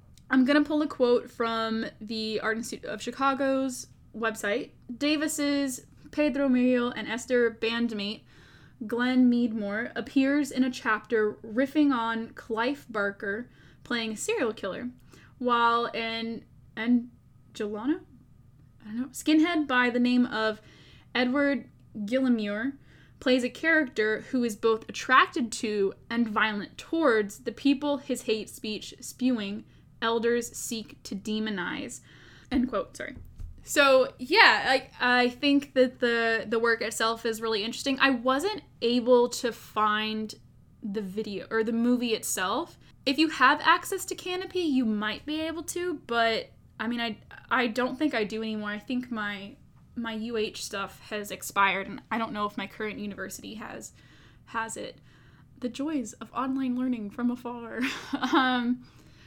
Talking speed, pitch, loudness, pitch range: 145 wpm, 240 Hz, -27 LUFS, 220-265 Hz